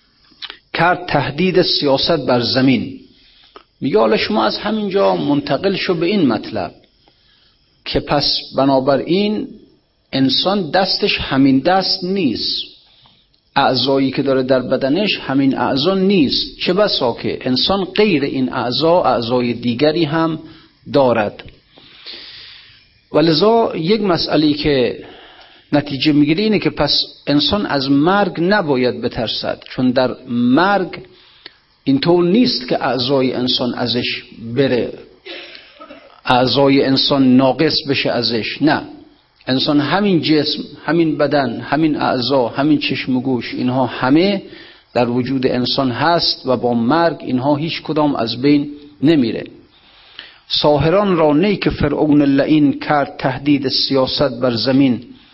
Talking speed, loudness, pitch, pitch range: 115 wpm, -15 LUFS, 145 Hz, 130-180 Hz